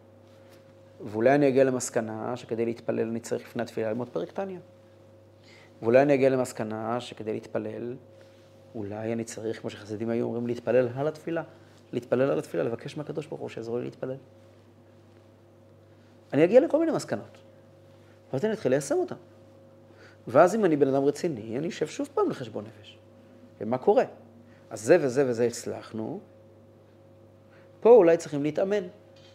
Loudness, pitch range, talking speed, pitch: -27 LUFS, 110-125 Hz, 145 wpm, 110 Hz